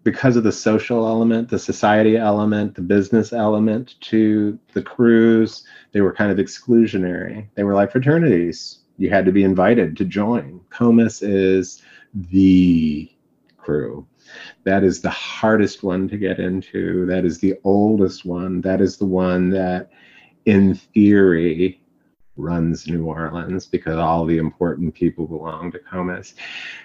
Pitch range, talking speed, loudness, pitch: 90-110 Hz, 145 wpm, -18 LUFS, 95 Hz